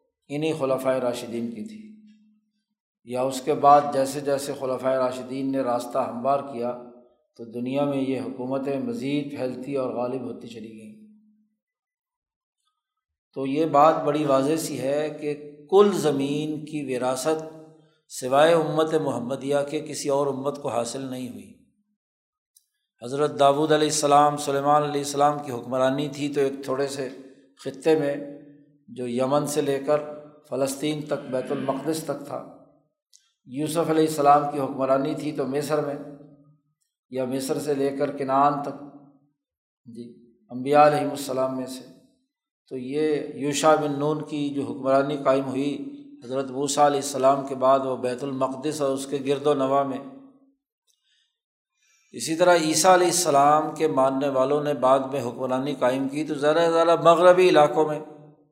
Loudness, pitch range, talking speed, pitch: -23 LUFS, 135-155 Hz, 150 wpm, 145 Hz